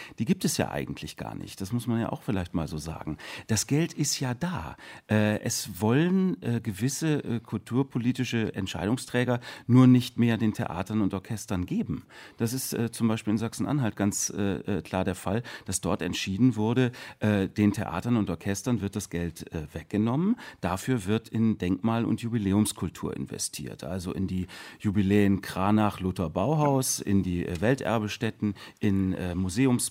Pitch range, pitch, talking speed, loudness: 95-125 Hz, 110 Hz, 145 wpm, -28 LUFS